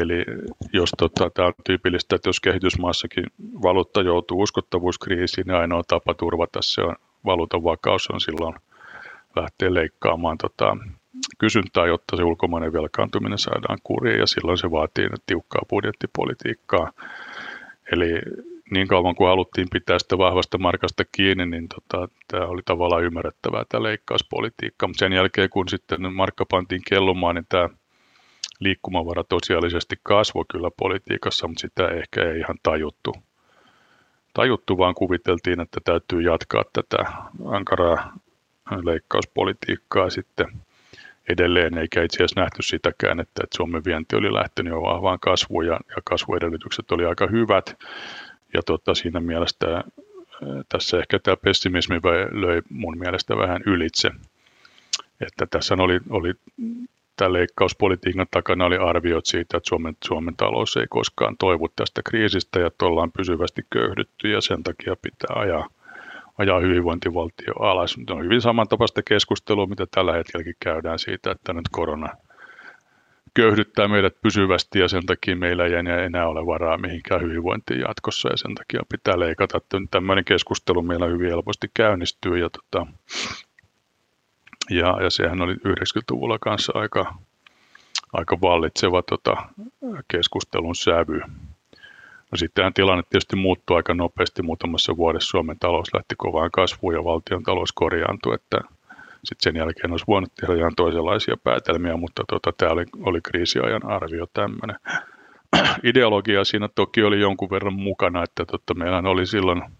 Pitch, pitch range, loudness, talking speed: 90 Hz, 85-100 Hz, -22 LUFS, 135 wpm